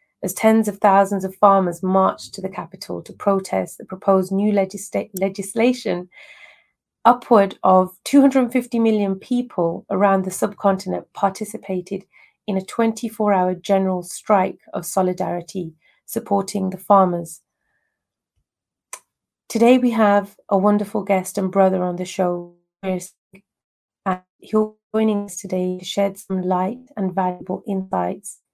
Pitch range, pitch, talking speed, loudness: 185-215 Hz, 195 Hz, 125 wpm, -20 LUFS